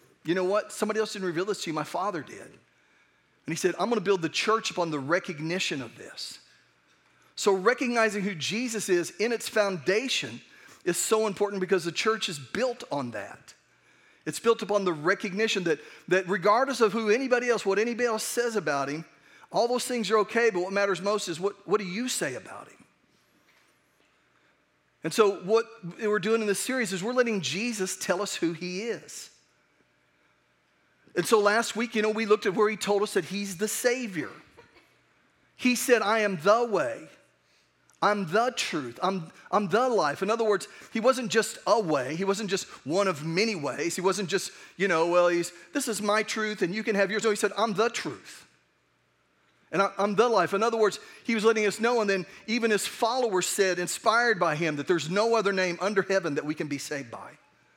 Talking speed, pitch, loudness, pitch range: 205 wpm, 200 Hz, -27 LUFS, 180-225 Hz